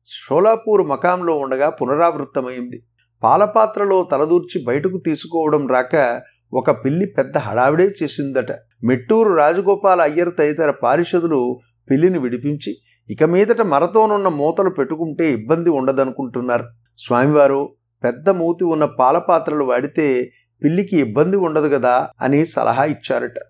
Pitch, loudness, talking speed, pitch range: 150 Hz, -17 LUFS, 105 wpm, 130-180 Hz